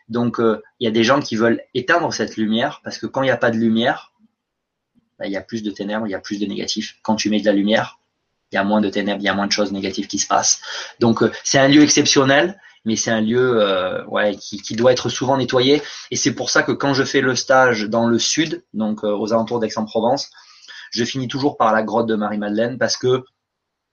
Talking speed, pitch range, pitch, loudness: 260 wpm, 110-130 Hz, 115 Hz, -18 LUFS